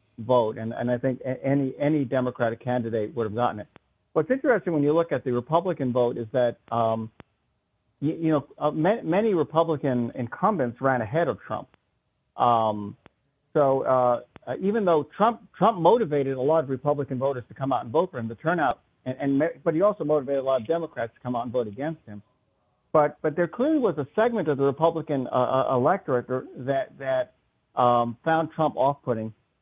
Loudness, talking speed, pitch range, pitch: -25 LUFS, 195 wpm, 120-155 Hz, 135 Hz